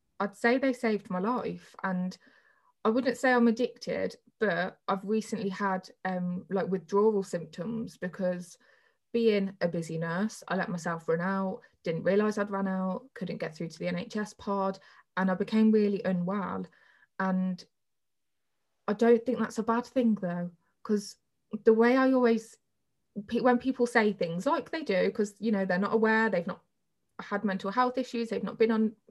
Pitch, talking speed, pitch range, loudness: 205 Hz, 175 wpm, 185-230 Hz, -29 LUFS